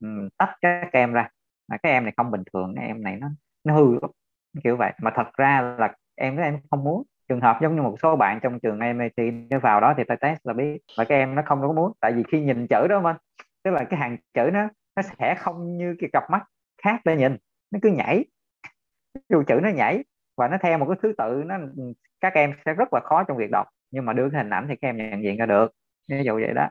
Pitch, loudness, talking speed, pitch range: 140 Hz, -23 LUFS, 265 wpm, 120-165 Hz